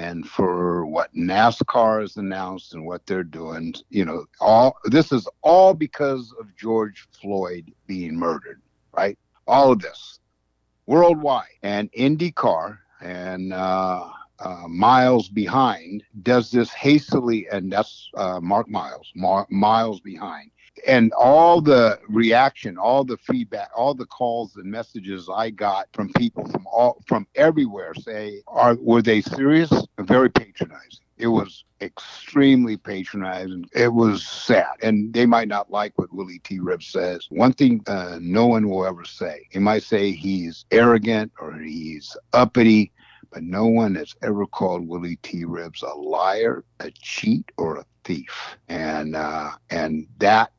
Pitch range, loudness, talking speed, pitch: 95-120 Hz, -20 LUFS, 150 wpm, 105 Hz